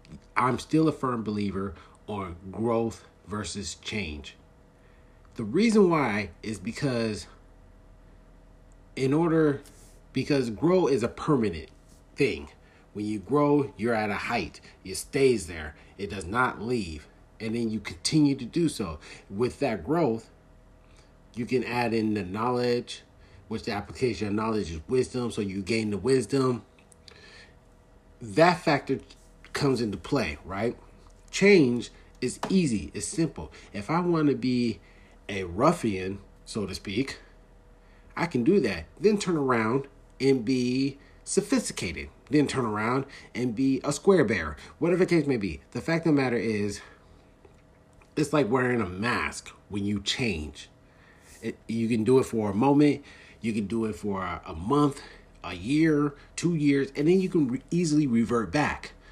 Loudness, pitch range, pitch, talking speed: -27 LUFS, 95-140 Hz, 115 Hz, 150 wpm